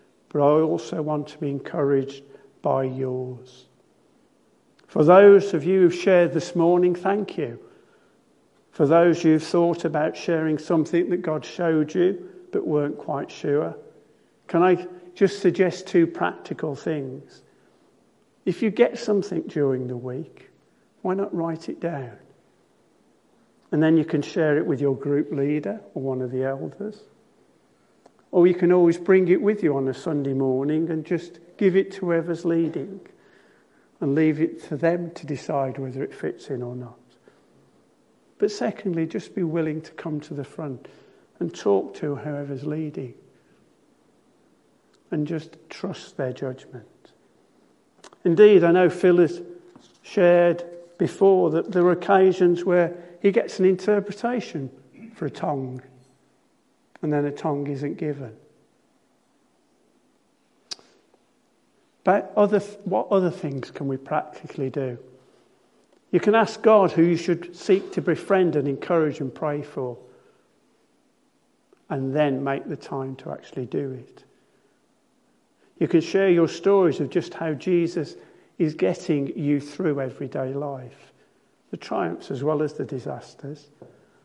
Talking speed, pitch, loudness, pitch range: 140 wpm, 165 Hz, -23 LUFS, 140-180 Hz